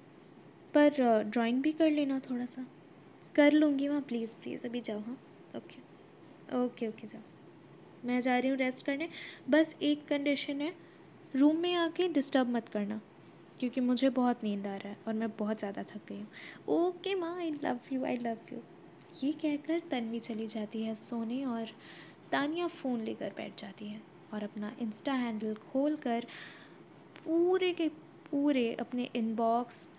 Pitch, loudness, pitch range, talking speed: 250 Hz, -33 LUFS, 225-295 Hz, 165 wpm